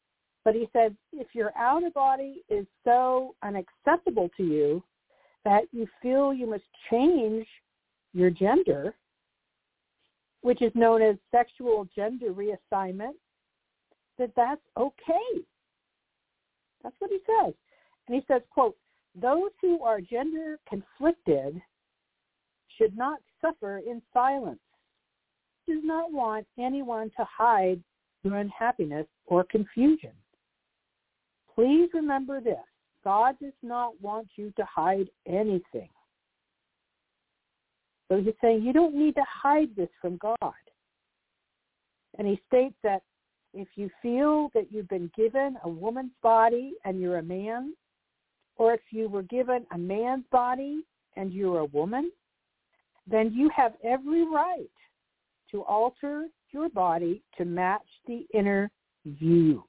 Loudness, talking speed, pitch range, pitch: -27 LUFS, 125 wpm, 200-275 Hz, 235 Hz